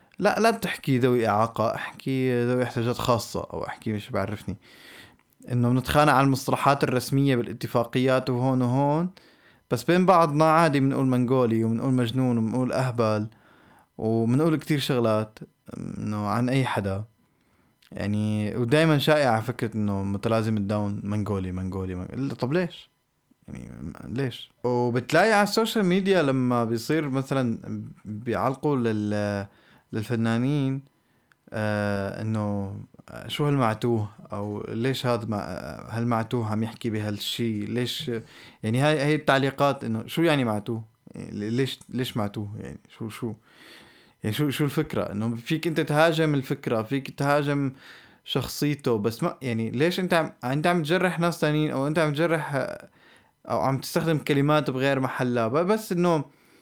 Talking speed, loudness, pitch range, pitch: 130 wpm, -25 LUFS, 110-145 Hz, 125 Hz